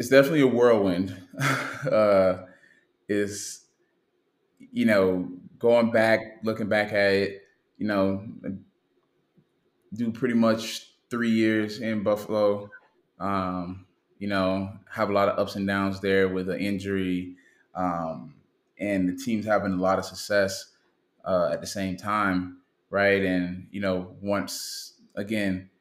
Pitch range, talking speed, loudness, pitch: 95-110 Hz, 135 wpm, -26 LUFS, 100 Hz